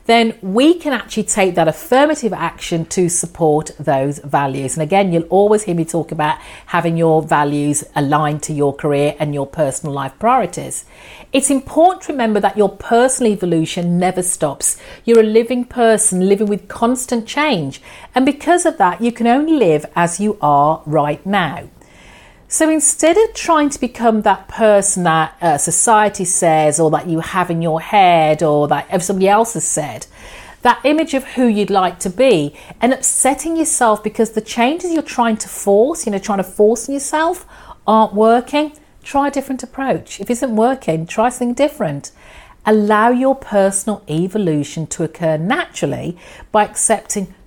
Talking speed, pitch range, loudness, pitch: 170 wpm, 160-245 Hz, -15 LUFS, 205 Hz